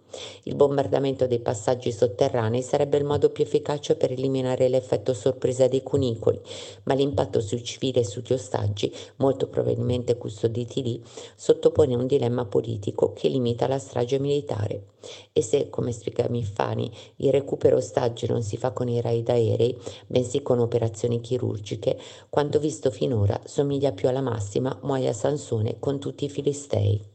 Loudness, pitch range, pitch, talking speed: -25 LUFS, 120-145 Hz, 130 Hz, 150 wpm